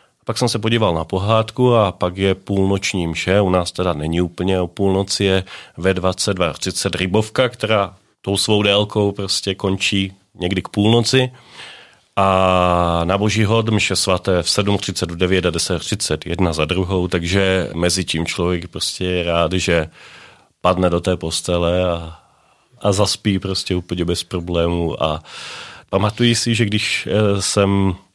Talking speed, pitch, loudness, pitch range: 150 wpm, 95 Hz, -18 LUFS, 90-100 Hz